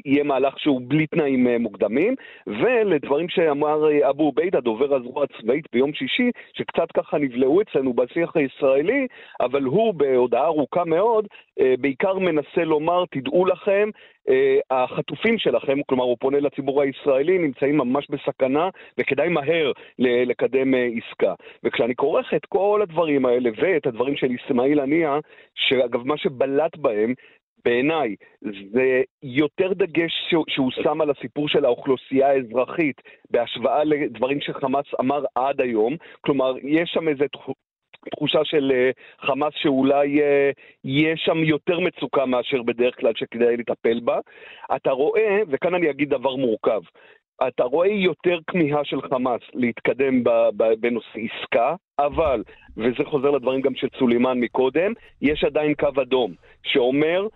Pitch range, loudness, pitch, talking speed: 130-175 Hz, -21 LUFS, 145 Hz, 130 wpm